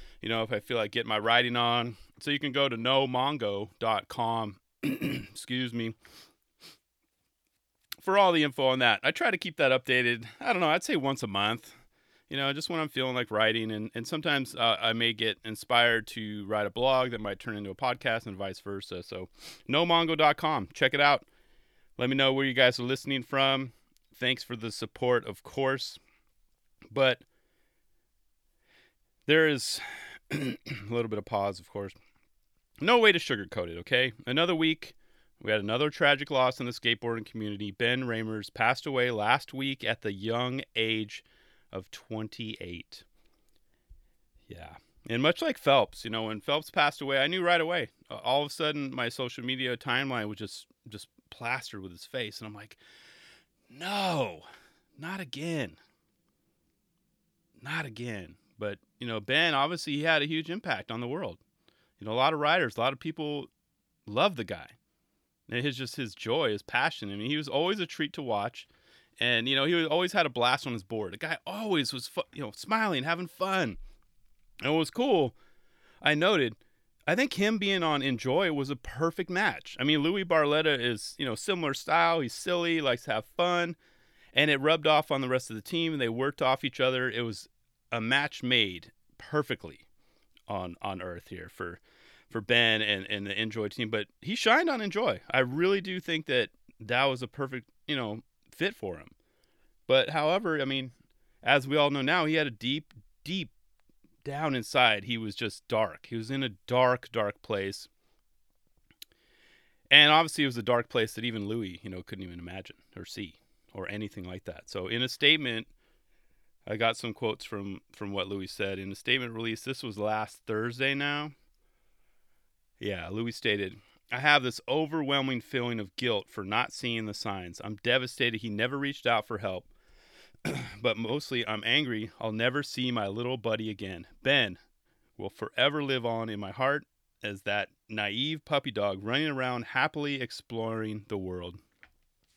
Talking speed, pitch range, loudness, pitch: 180 wpm, 110-145 Hz, -29 LUFS, 125 Hz